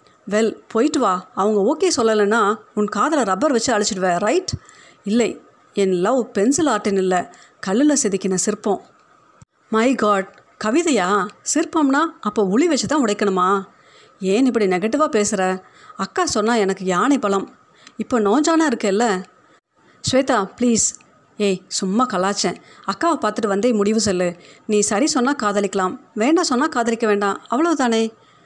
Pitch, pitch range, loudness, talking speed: 215 Hz, 200-265 Hz, -19 LUFS, 130 wpm